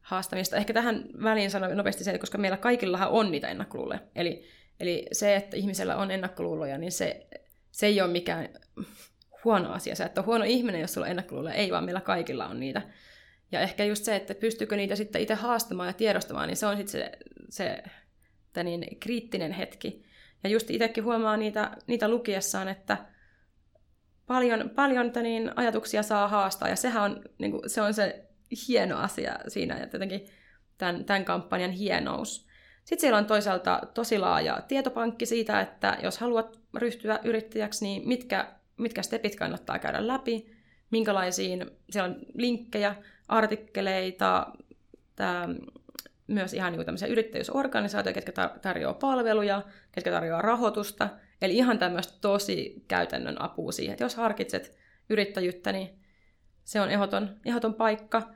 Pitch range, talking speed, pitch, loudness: 195-235 Hz, 150 wpm, 215 Hz, -29 LUFS